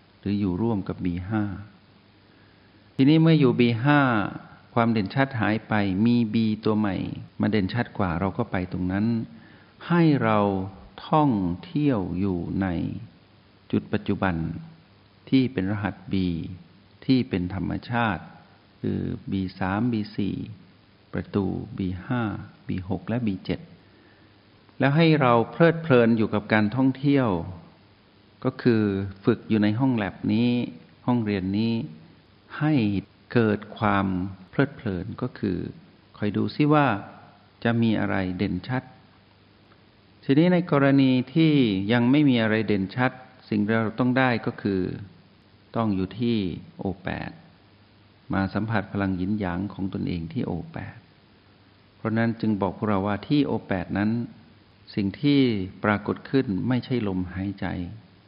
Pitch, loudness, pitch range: 105 Hz, -25 LUFS, 95-120 Hz